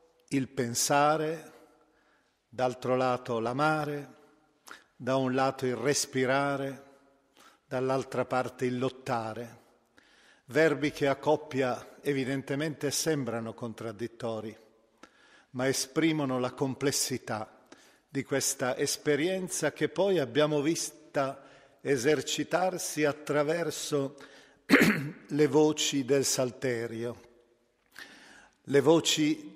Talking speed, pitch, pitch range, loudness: 80 wpm, 140 Hz, 125-150 Hz, -29 LUFS